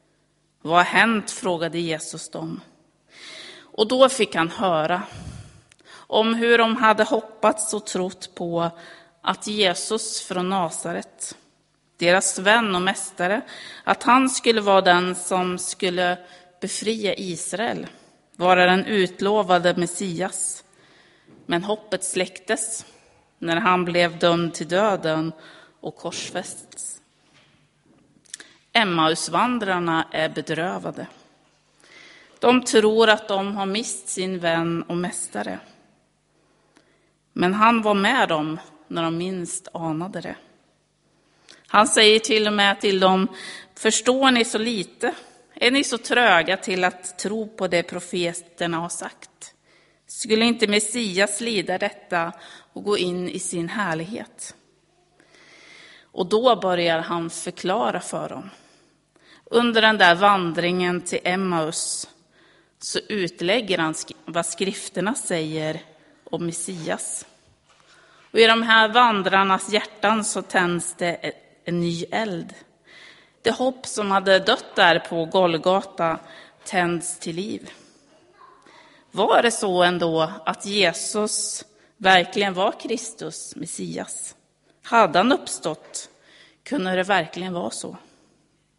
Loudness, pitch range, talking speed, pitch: -21 LUFS, 175-215 Hz, 115 wpm, 185 Hz